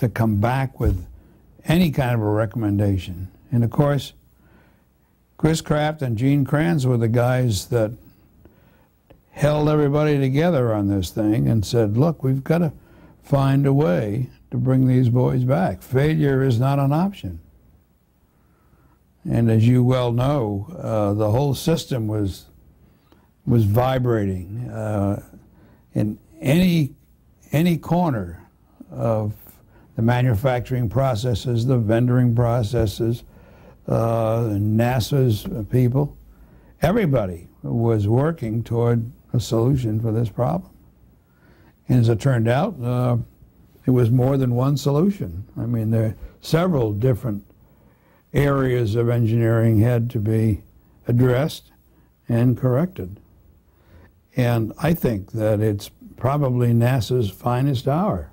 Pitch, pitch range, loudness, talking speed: 120 Hz, 110-135 Hz, -21 LUFS, 120 wpm